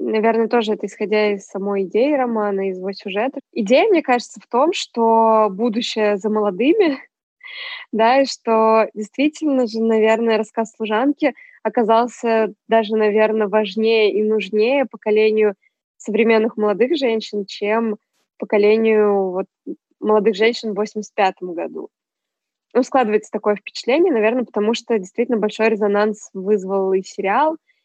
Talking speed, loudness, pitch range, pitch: 125 wpm, -18 LUFS, 210-240 Hz, 220 Hz